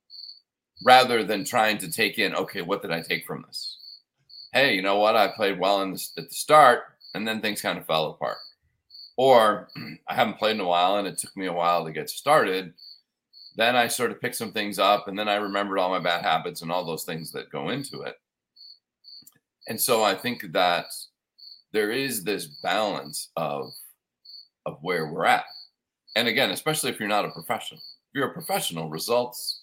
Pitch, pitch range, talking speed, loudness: 100 Hz, 85-110 Hz, 200 wpm, -24 LUFS